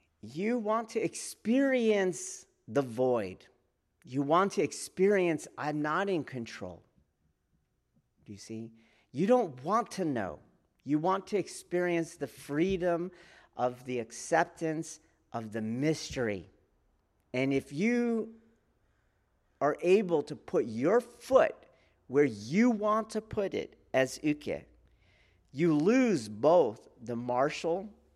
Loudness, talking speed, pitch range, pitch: -31 LUFS, 120 wpm, 125-200 Hz, 165 Hz